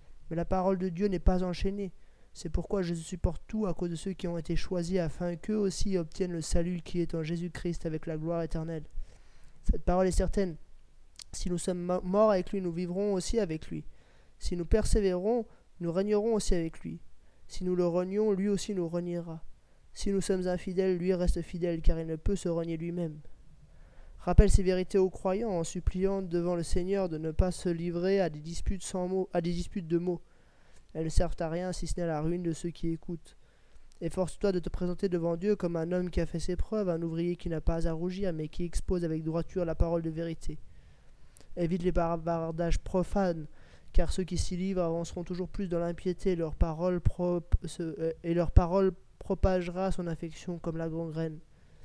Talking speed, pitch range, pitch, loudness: 205 wpm, 165-185 Hz, 175 Hz, -32 LUFS